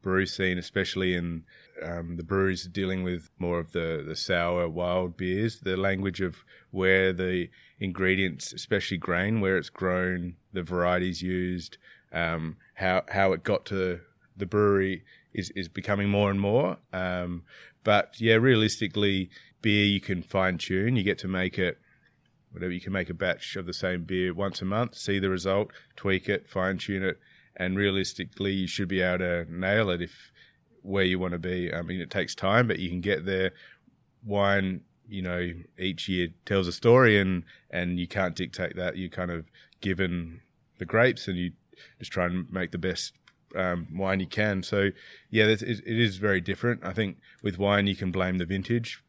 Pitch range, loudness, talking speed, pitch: 90-100 Hz, -28 LUFS, 185 wpm, 95 Hz